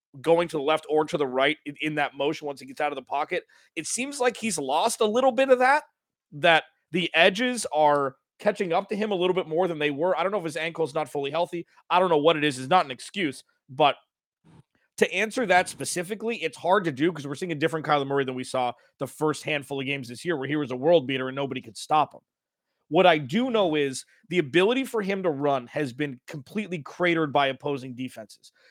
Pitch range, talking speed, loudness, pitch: 140-185 Hz, 245 wpm, -25 LUFS, 160 Hz